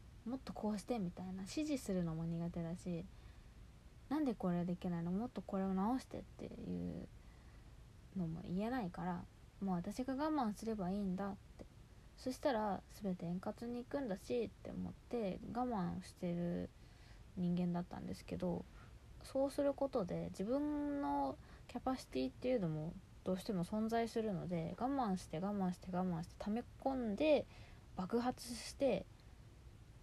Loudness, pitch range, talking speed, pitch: -42 LUFS, 175-245 Hz, 310 characters per minute, 195 Hz